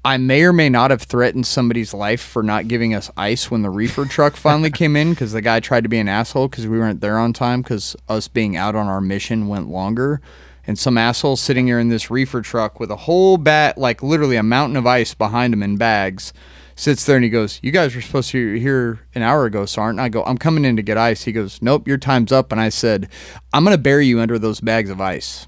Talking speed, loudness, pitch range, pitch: 260 wpm, -17 LUFS, 110-135 Hz, 115 Hz